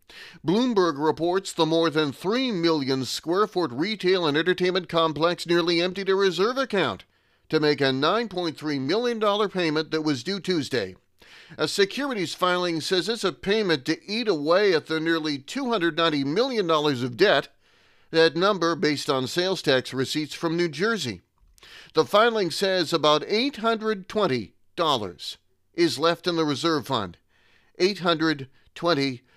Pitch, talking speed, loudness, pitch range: 170 Hz, 135 wpm, -24 LUFS, 150-190 Hz